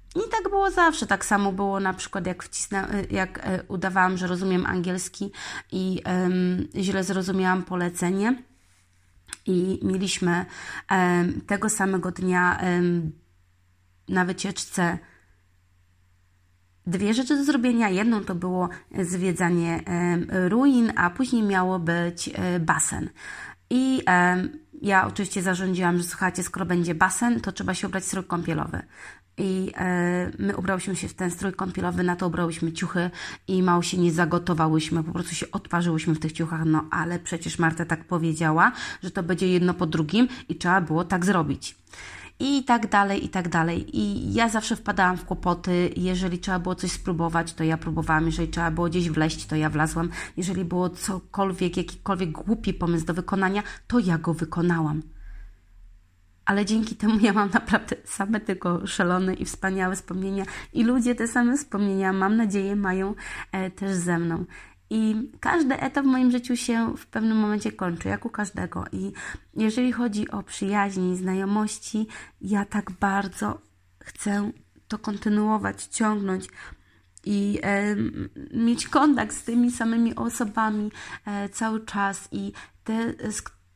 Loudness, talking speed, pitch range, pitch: -25 LUFS, 150 wpm, 175-205 Hz, 185 Hz